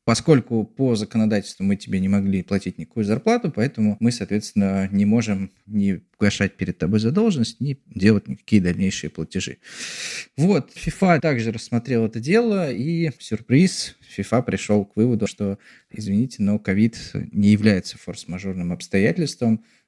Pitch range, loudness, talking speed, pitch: 100-120 Hz, -22 LUFS, 140 wpm, 105 Hz